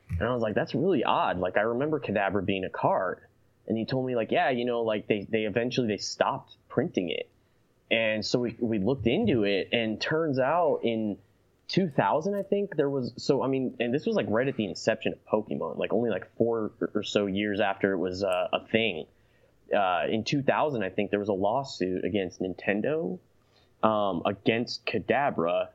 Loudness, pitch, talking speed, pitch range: -28 LUFS, 110 Hz, 200 wpm, 100-130 Hz